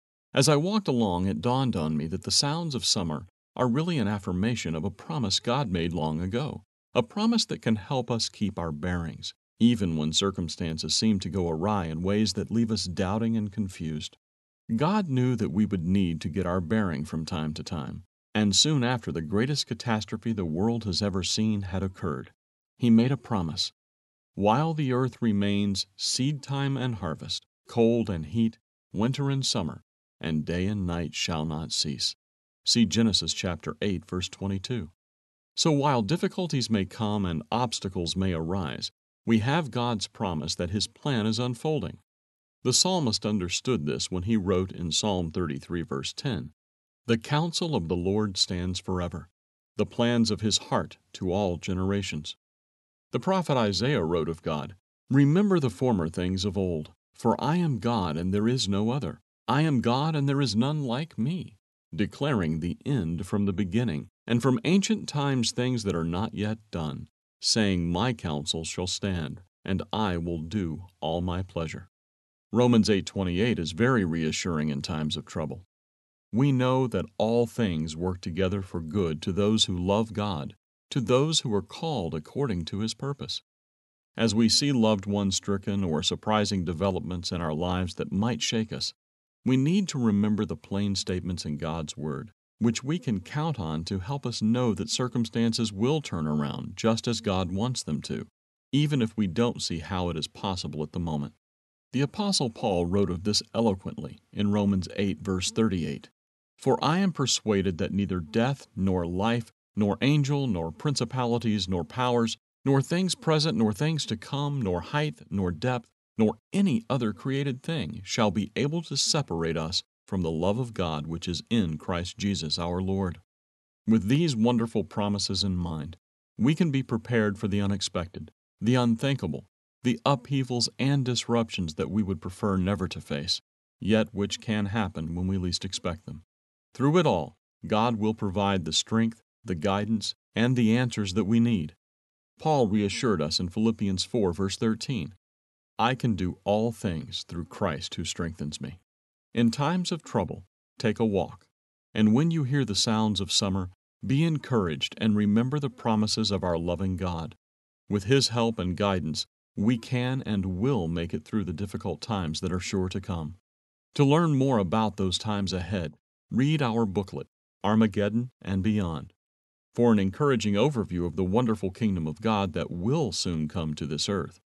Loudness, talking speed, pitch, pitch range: -27 LUFS, 175 wpm, 105 Hz, 90-120 Hz